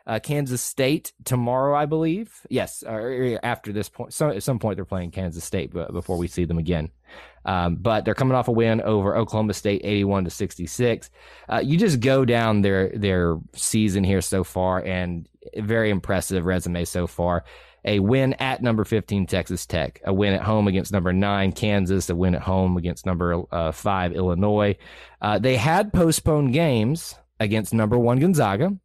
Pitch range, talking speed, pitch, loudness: 90-120 Hz, 180 wpm, 100 Hz, -23 LUFS